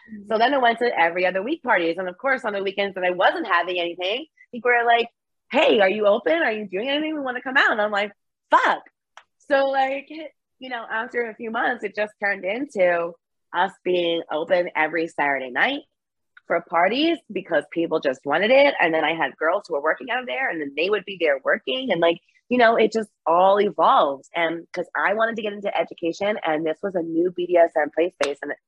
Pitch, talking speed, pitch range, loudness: 200 Hz, 230 wpm, 170-240 Hz, -22 LUFS